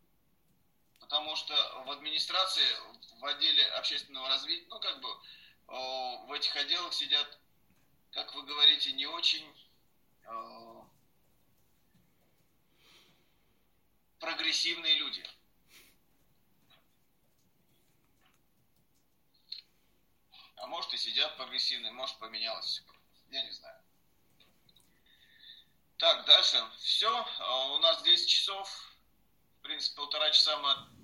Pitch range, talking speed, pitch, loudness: 140-195 Hz, 90 wpm, 155 Hz, -29 LUFS